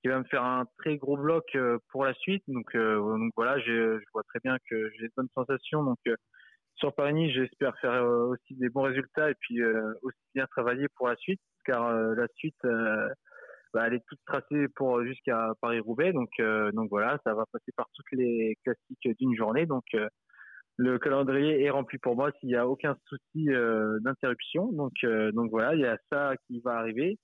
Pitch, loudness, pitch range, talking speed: 125 Hz, -30 LUFS, 115-135 Hz, 210 wpm